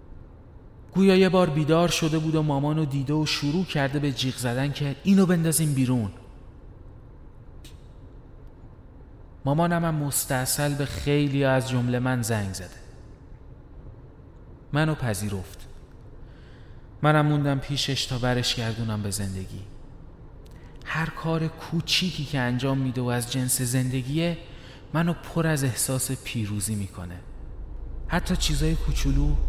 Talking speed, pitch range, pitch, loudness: 115 wpm, 115-155 Hz, 135 Hz, -25 LUFS